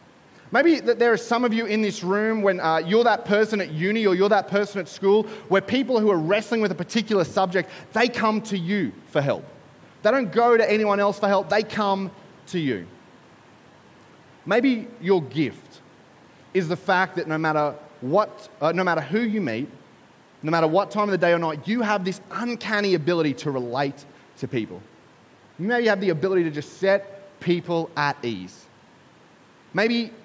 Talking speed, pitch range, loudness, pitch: 190 wpm, 170-215 Hz, -23 LUFS, 195 Hz